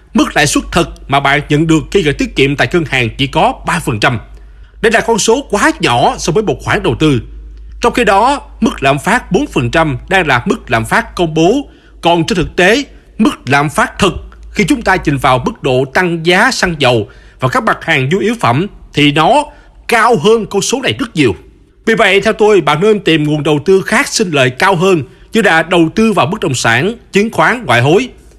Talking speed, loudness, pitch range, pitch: 225 wpm, -11 LUFS, 140-220 Hz, 175 Hz